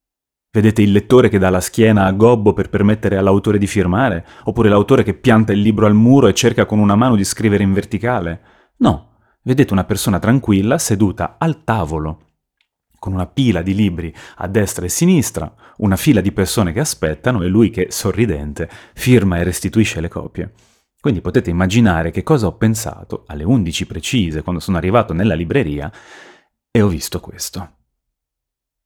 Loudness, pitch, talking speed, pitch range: -15 LUFS, 100 Hz, 170 wpm, 90-115 Hz